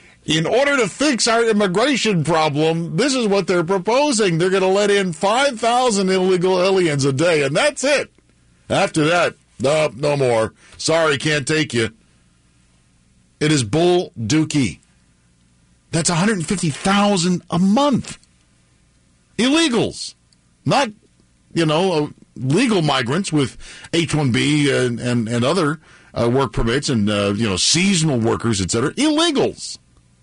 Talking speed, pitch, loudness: 130 wpm, 155 Hz, -18 LUFS